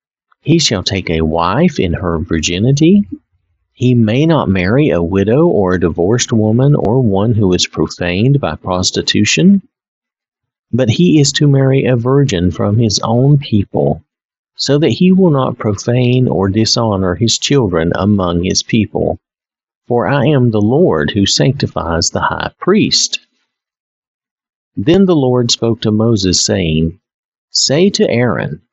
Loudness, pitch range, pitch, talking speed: -12 LUFS, 90-135 Hz, 115 Hz, 145 wpm